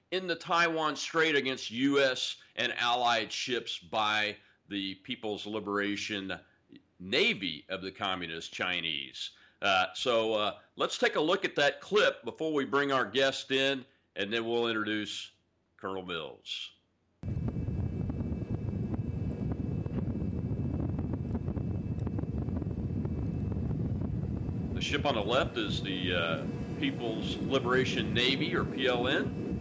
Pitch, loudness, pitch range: 110 Hz, -32 LUFS, 100-135 Hz